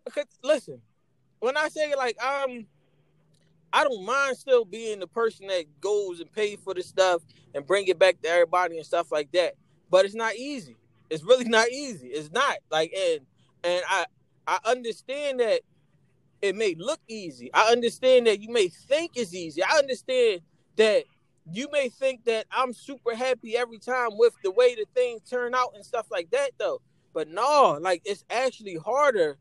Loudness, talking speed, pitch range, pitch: -26 LUFS, 180 wpm, 185-280 Hz, 230 Hz